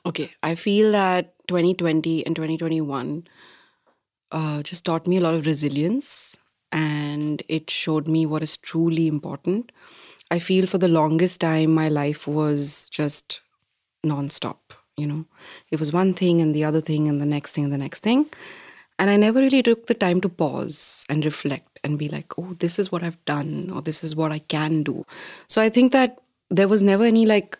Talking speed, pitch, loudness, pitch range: 190 wpm, 160 Hz, -22 LUFS, 150-185 Hz